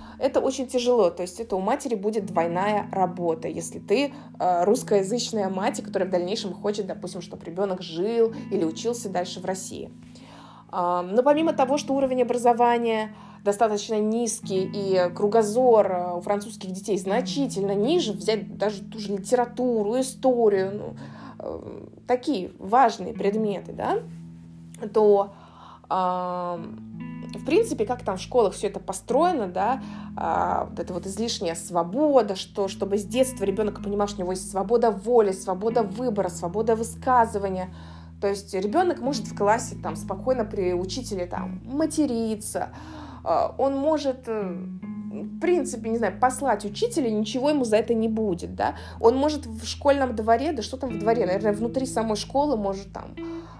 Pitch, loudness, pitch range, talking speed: 210 Hz, -25 LUFS, 190-240 Hz, 145 wpm